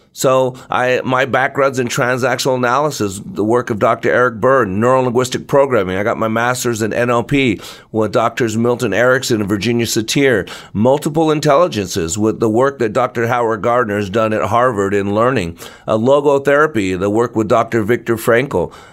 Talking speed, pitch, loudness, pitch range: 160 wpm, 120 Hz, -15 LUFS, 110-130 Hz